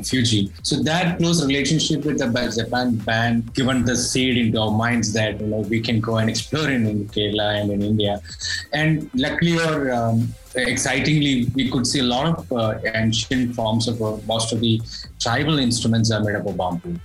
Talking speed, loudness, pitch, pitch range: 190 wpm, -20 LUFS, 115 Hz, 110-130 Hz